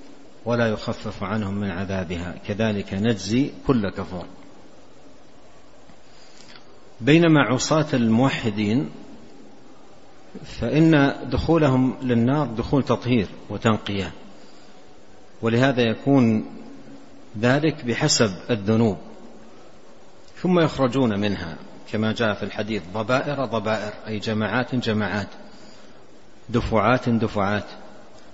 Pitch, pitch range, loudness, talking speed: 115 Hz, 105-130 Hz, -22 LUFS, 80 wpm